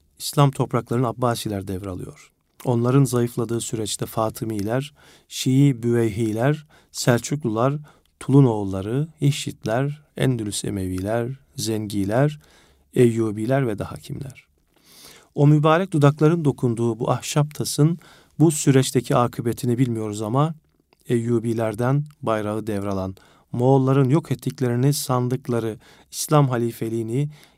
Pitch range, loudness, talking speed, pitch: 115-140 Hz, -22 LUFS, 85 wpm, 125 Hz